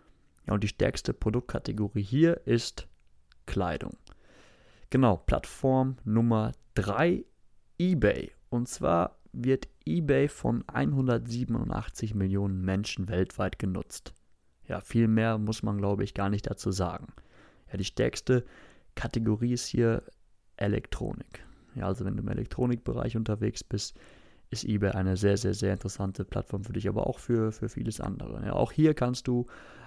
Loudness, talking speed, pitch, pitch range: -30 LUFS, 140 wpm, 110 Hz, 100-120 Hz